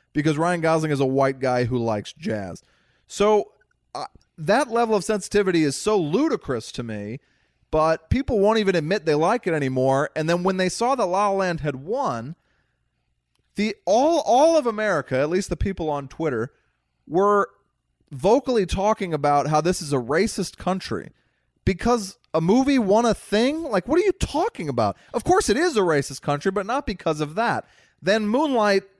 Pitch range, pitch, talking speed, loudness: 145-215 Hz, 185 Hz, 180 wpm, -22 LUFS